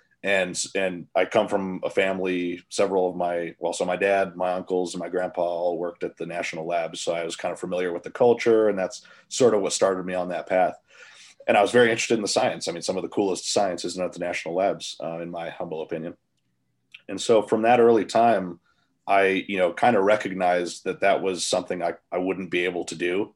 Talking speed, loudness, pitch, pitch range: 235 wpm, -24 LUFS, 90 Hz, 85-100 Hz